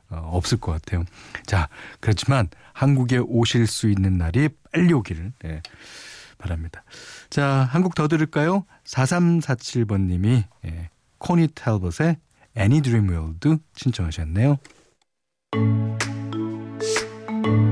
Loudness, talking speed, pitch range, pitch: -22 LUFS, 230 characters per minute, 95-140 Hz, 110 Hz